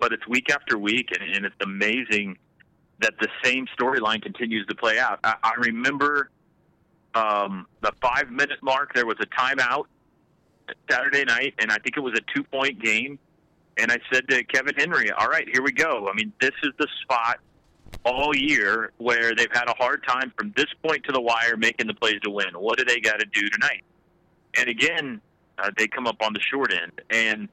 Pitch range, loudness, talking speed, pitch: 110-140 Hz, -23 LUFS, 205 wpm, 120 Hz